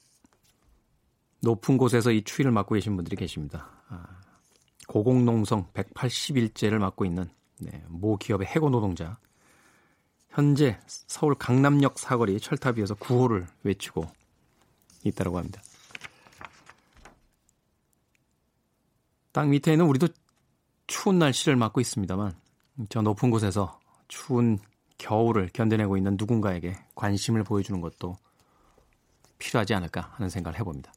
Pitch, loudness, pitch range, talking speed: 110 Hz, -26 LUFS, 95-125 Hz, 260 characters per minute